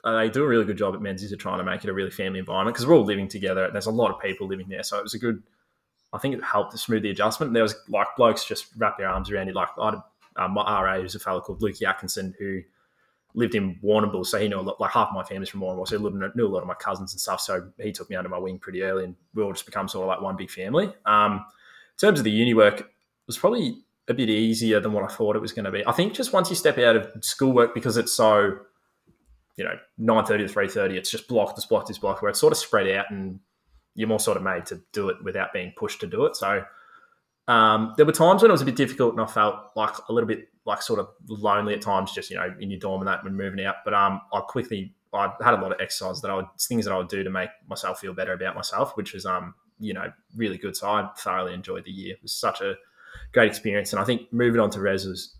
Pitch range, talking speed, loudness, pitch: 95-115 Hz, 295 wpm, -24 LUFS, 105 Hz